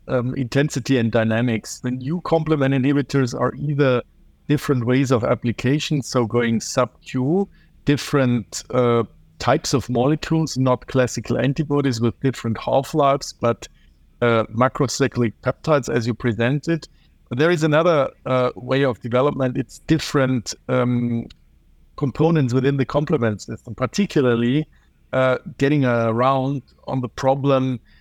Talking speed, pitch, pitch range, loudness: 130 wpm, 130 Hz, 120-140 Hz, -20 LUFS